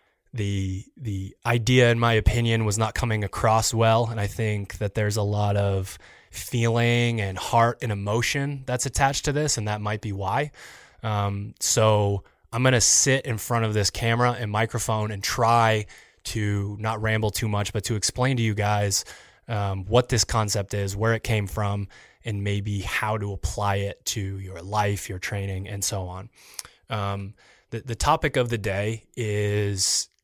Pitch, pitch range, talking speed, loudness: 110 Hz, 100-115 Hz, 175 wpm, -24 LUFS